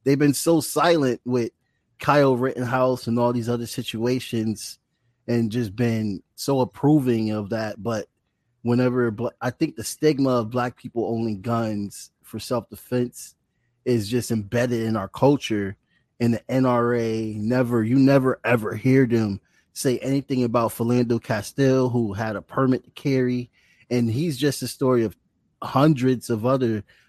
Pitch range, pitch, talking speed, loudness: 115-130 Hz, 120 Hz, 155 wpm, -23 LUFS